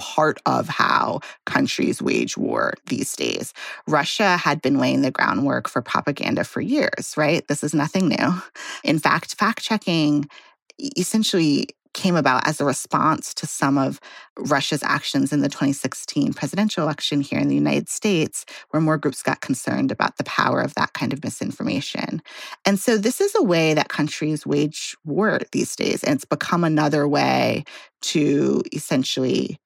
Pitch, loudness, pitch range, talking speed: 150 Hz, -21 LUFS, 145-185 Hz, 160 wpm